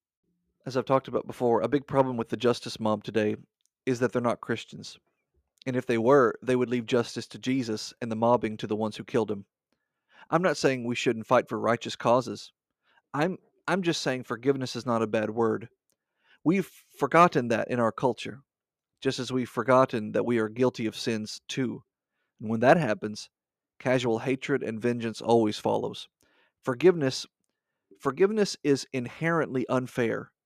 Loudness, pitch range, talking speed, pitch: -27 LUFS, 115-135 Hz, 175 wpm, 125 Hz